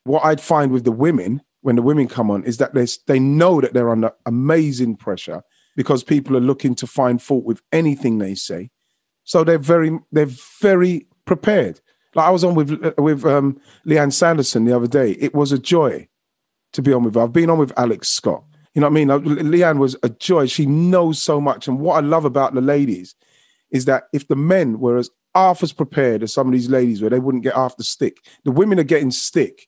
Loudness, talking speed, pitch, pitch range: -17 LUFS, 225 wpm, 140 Hz, 125-160 Hz